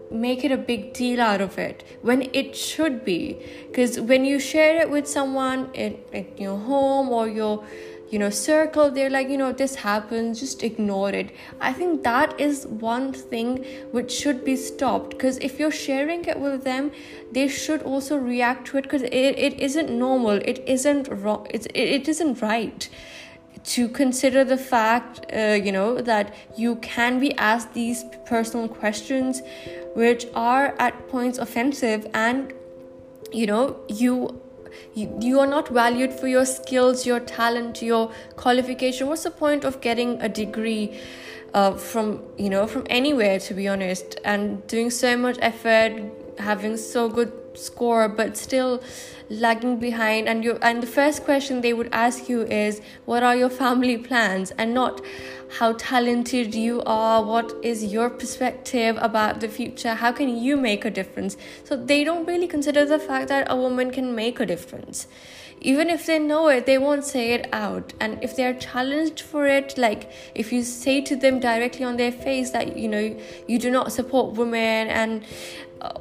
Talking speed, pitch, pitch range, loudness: 175 wpm, 245 Hz, 225-270 Hz, -23 LUFS